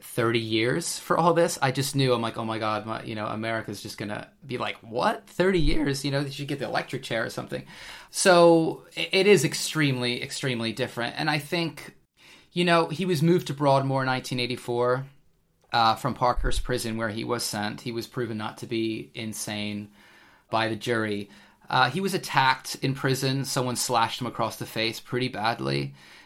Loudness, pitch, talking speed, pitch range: -26 LUFS, 125 Hz, 190 wpm, 110-145 Hz